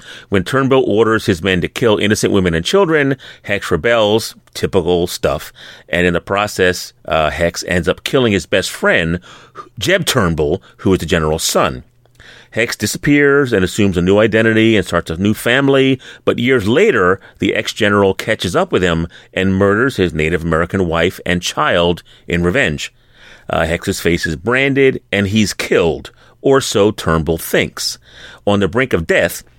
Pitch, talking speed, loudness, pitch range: 100 Hz, 170 wpm, -15 LUFS, 85-115 Hz